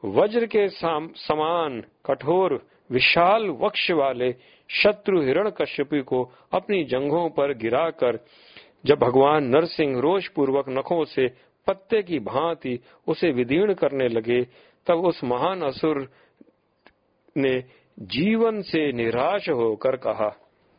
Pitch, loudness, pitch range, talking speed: 150 Hz, -23 LUFS, 130-180 Hz, 115 wpm